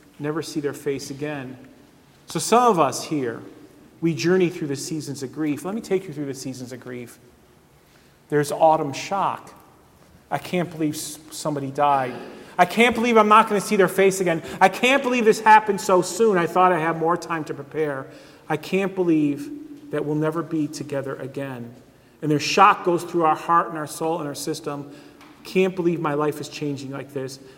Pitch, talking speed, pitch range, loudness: 155 Hz, 195 wpm, 145-180 Hz, -22 LUFS